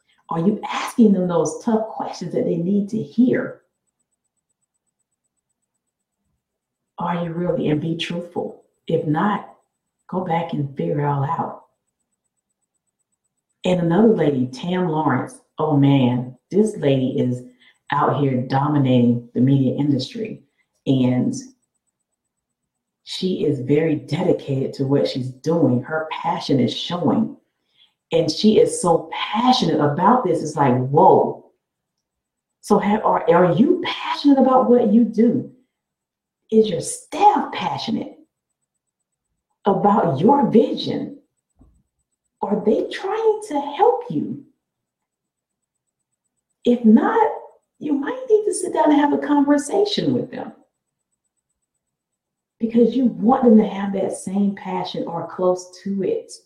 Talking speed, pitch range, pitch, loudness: 120 wpm, 155-250 Hz, 200 Hz, -19 LUFS